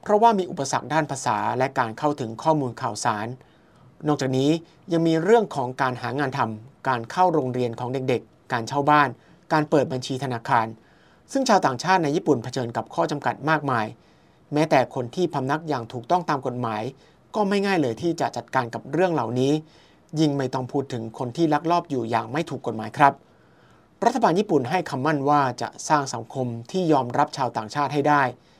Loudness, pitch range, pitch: -24 LUFS, 125-160 Hz, 140 Hz